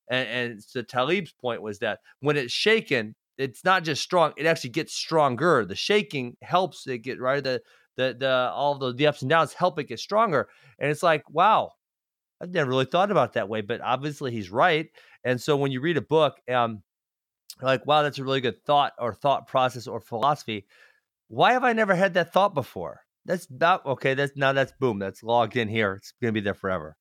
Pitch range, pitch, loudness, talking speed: 120-155 Hz, 135 Hz, -25 LUFS, 215 wpm